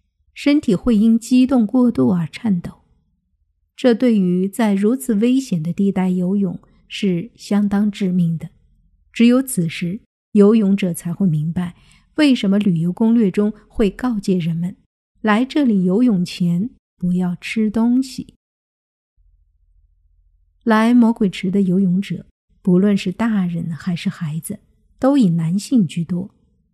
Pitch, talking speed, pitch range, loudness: 195 Hz, 195 characters per minute, 175-225 Hz, -18 LUFS